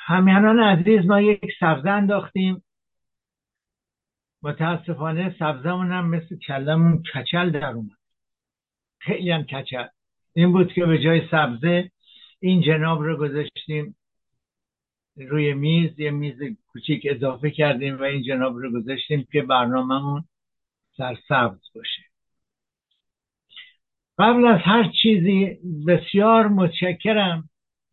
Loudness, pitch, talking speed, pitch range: -21 LUFS, 165 Hz, 105 wpm, 145-185 Hz